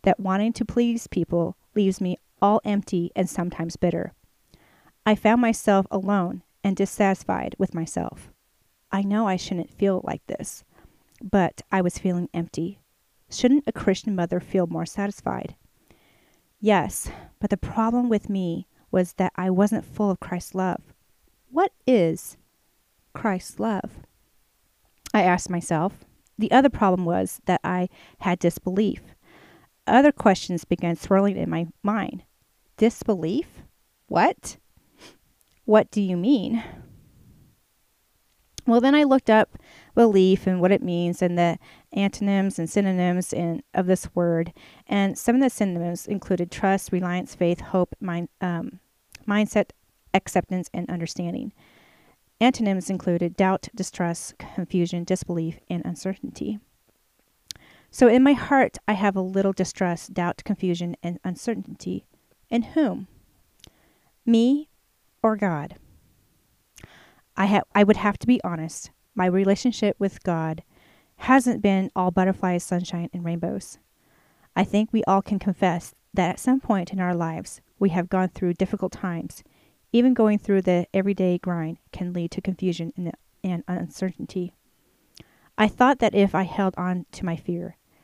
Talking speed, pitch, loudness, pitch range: 140 wpm, 190 Hz, -24 LUFS, 175-210 Hz